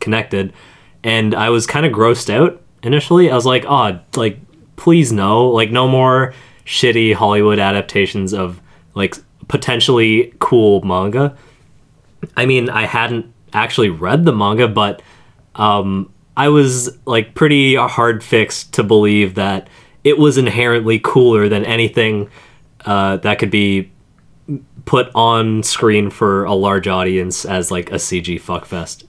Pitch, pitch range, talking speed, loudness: 115 Hz, 100-125 Hz, 140 wpm, -14 LUFS